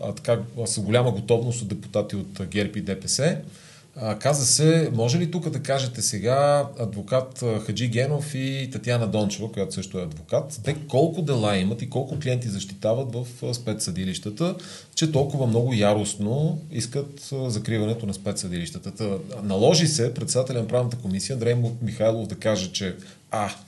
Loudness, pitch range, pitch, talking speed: -25 LUFS, 105-135 Hz, 120 Hz, 150 wpm